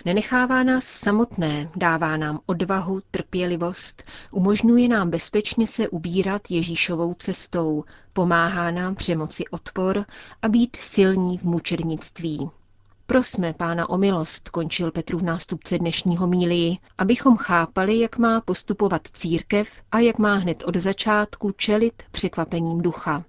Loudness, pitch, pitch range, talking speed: -22 LUFS, 180 Hz, 170-205 Hz, 125 wpm